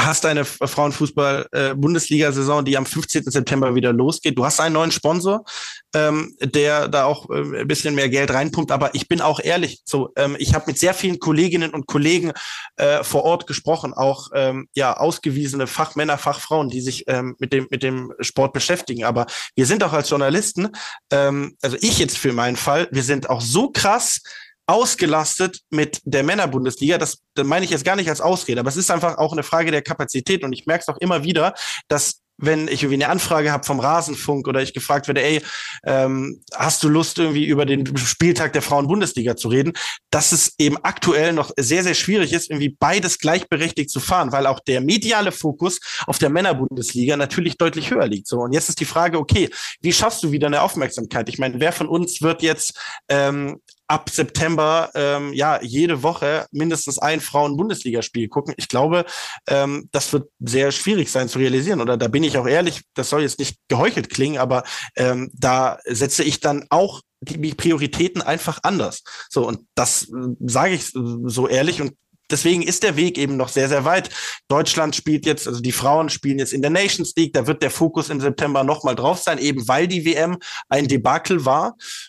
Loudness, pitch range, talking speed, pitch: -19 LUFS, 135-165 Hz, 195 wpm, 150 Hz